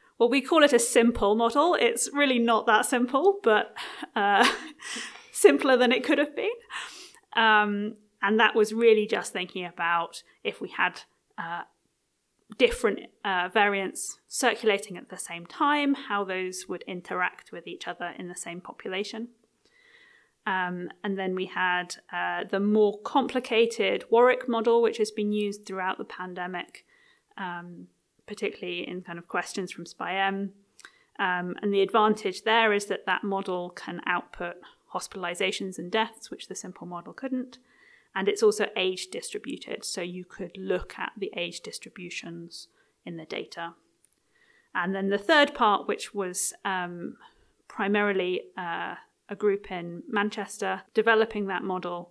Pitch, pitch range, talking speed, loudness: 205 Hz, 185-245 Hz, 150 wpm, -27 LUFS